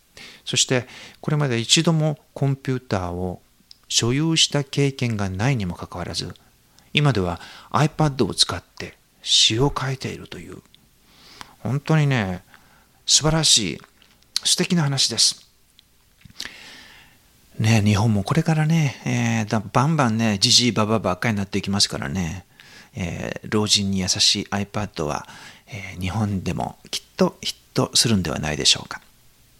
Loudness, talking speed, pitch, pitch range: -20 LUFS, 290 characters per minute, 115 Hz, 100-140 Hz